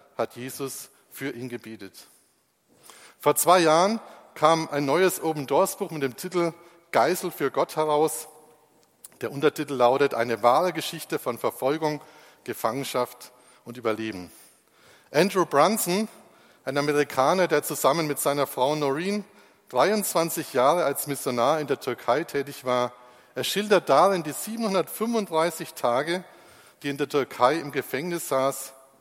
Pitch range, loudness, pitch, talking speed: 130-170 Hz, -25 LUFS, 150 Hz, 130 wpm